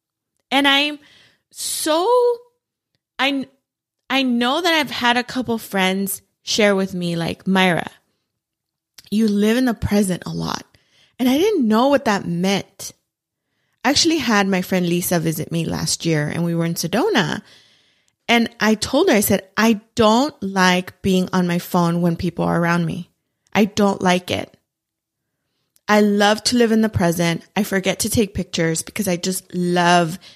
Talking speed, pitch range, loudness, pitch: 165 wpm, 175-235 Hz, -18 LUFS, 195 Hz